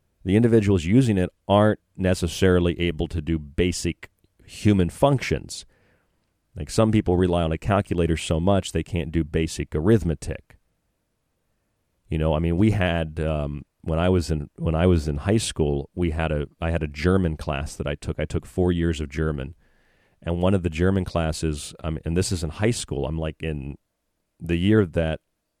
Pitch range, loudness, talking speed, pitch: 80-95 Hz, -23 LUFS, 185 wpm, 85 Hz